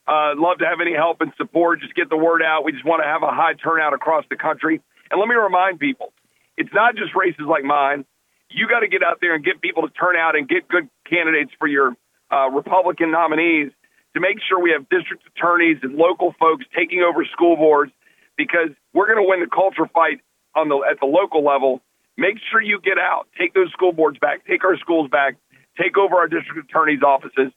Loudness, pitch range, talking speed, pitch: -18 LUFS, 150-180 Hz, 230 wpm, 165 Hz